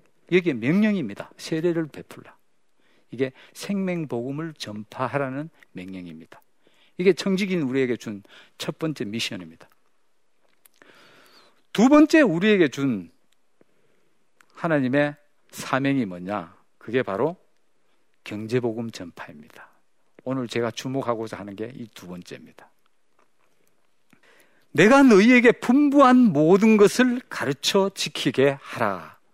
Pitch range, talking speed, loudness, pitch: 115-195 Hz, 240 characters per minute, -21 LUFS, 140 Hz